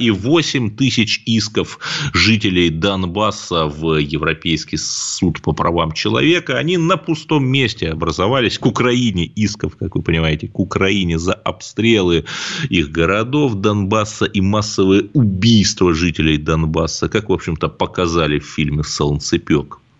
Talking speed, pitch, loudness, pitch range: 125 wpm, 100 Hz, -16 LUFS, 80-115 Hz